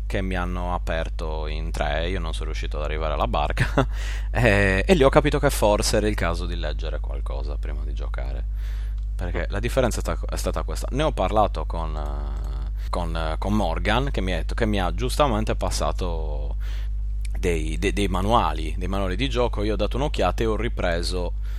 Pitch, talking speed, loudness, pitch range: 95 Hz, 185 wpm, -25 LUFS, 85-105 Hz